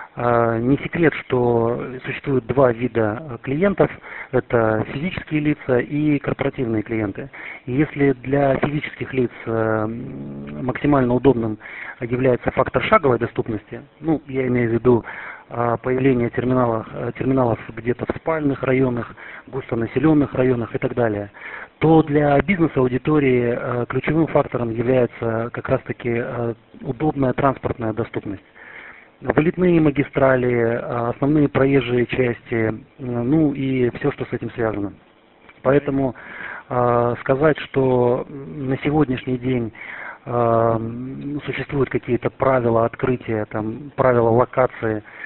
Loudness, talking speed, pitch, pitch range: -20 LUFS, 105 wpm, 125 Hz, 120-140 Hz